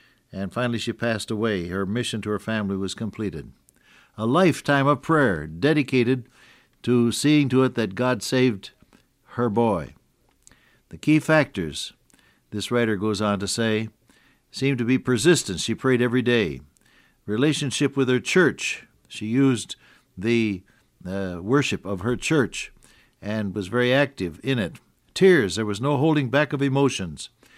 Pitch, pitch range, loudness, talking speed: 120 Hz, 105-135 Hz, -23 LUFS, 150 wpm